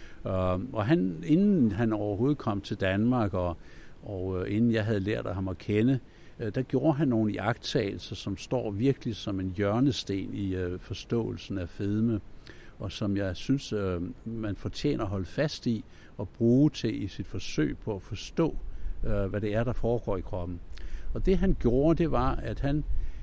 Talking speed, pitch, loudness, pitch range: 170 wpm, 105 Hz, -30 LUFS, 95-120 Hz